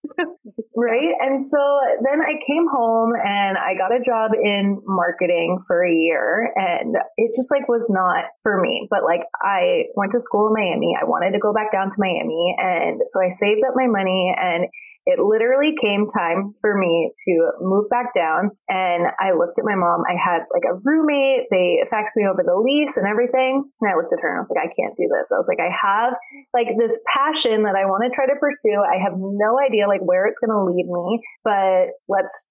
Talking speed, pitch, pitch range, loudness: 220 wpm, 220 Hz, 195-275 Hz, -19 LUFS